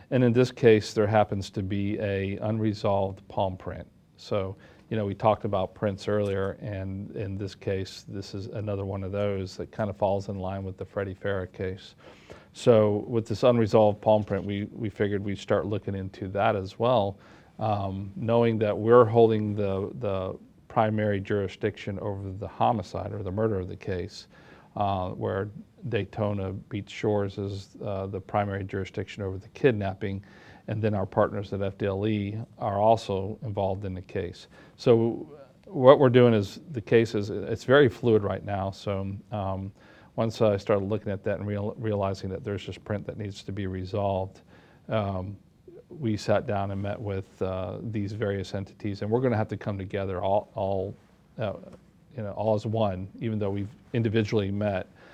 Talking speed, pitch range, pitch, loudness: 180 wpm, 95-110 Hz, 100 Hz, -27 LUFS